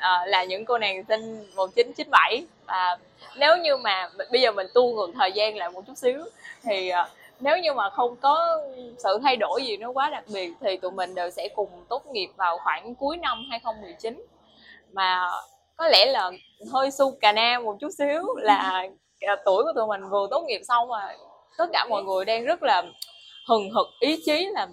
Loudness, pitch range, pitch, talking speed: -24 LUFS, 195-290 Hz, 235 Hz, 205 wpm